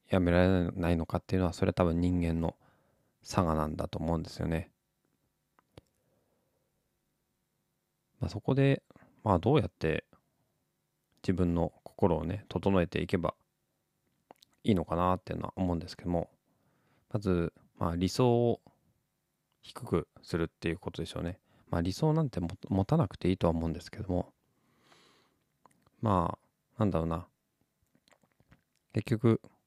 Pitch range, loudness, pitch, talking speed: 85-110 Hz, -32 LUFS, 90 Hz, 275 characters per minute